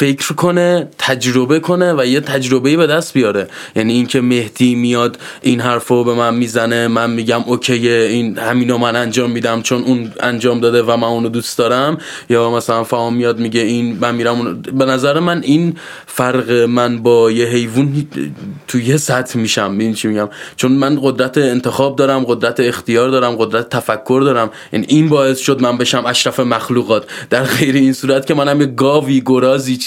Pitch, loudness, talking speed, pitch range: 125 Hz, -14 LUFS, 185 wpm, 120-135 Hz